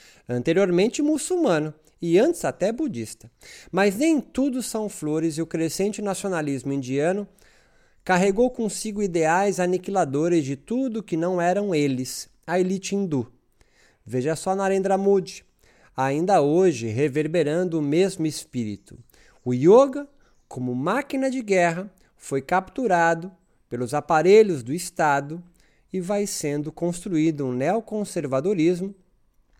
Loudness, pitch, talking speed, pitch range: -23 LUFS, 175 Hz, 115 wpm, 150-200 Hz